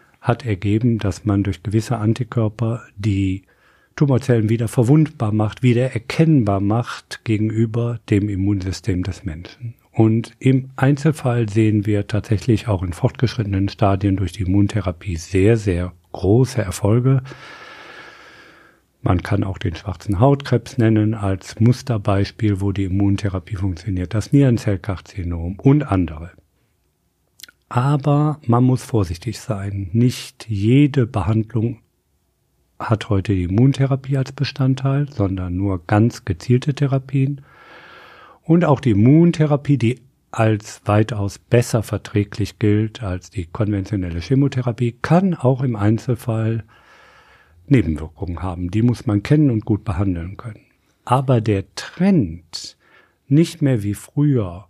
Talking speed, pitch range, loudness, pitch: 120 wpm, 100-125 Hz, -19 LUFS, 110 Hz